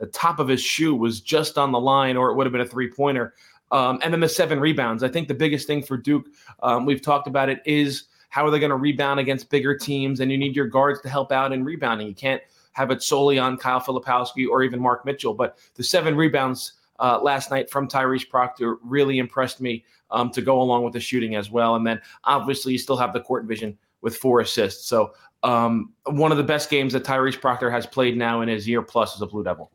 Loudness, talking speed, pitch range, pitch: -22 LUFS, 245 wpm, 120-140 Hz, 130 Hz